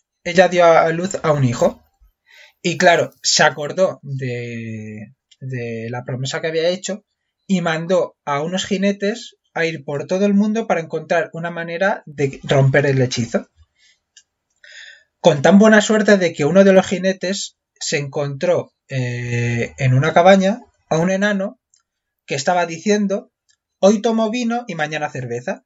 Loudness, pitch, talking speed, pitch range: -17 LUFS, 170 Hz, 150 wpm, 140-195 Hz